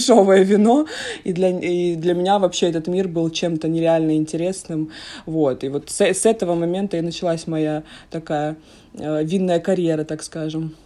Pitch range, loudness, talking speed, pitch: 155-185 Hz, -20 LUFS, 160 wpm, 170 Hz